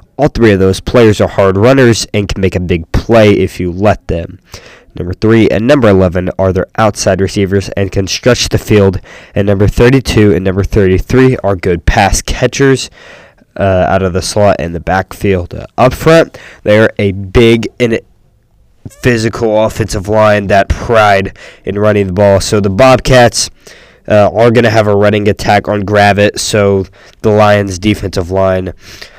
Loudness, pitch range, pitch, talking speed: -9 LUFS, 95-110 Hz, 100 Hz, 175 wpm